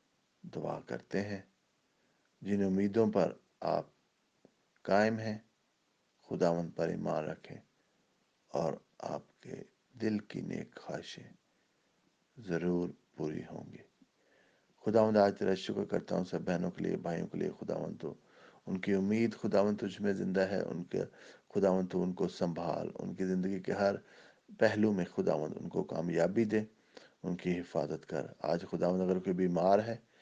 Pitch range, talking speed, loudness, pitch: 90-105 Hz, 145 wpm, -34 LUFS, 95 Hz